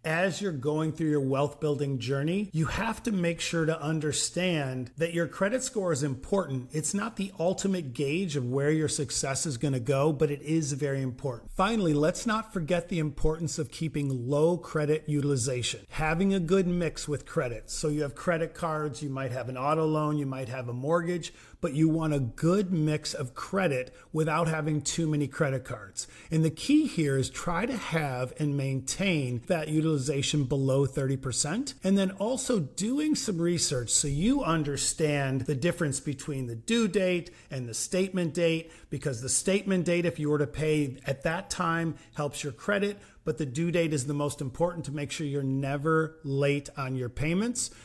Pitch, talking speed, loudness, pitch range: 155 Hz, 190 wpm, -29 LUFS, 140-175 Hz